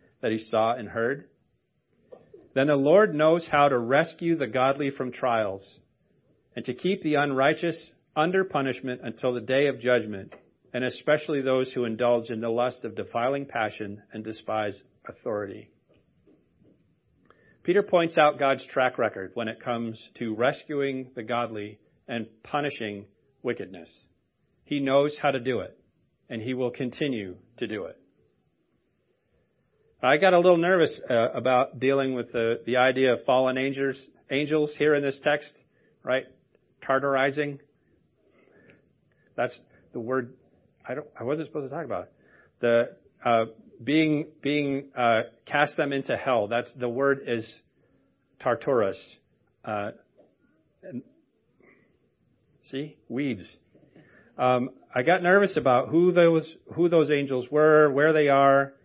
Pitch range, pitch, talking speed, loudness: 120-150 Hz, 130 Hz, 140 wpm, -25 LUFS